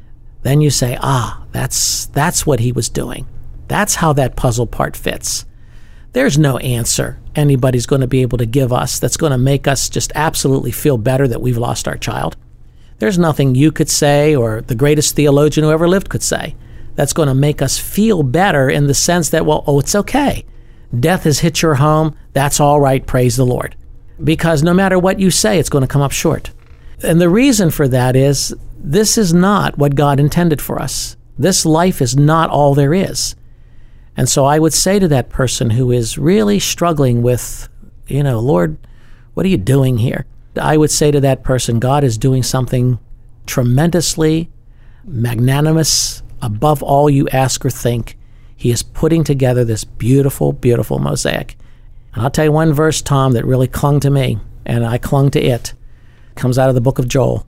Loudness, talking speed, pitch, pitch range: -14 LUFS, 195 wpm, 140 Hz, 125-155 Hz